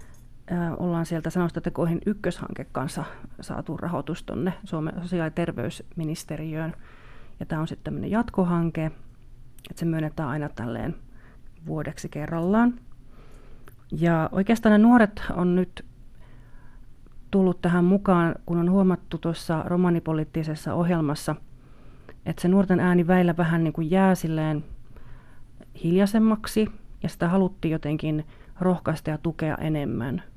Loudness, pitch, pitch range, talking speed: -25 LUFS, 170 Hz, 155-180 Hz, 115 wpm